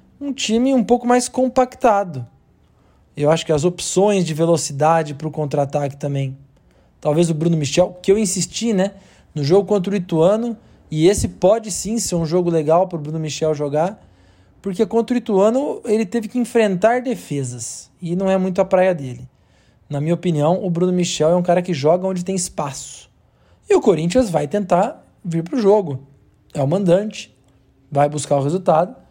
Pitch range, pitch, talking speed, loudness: 150-205 Hz, 175 Hz, 185 wpm, -18 LUFS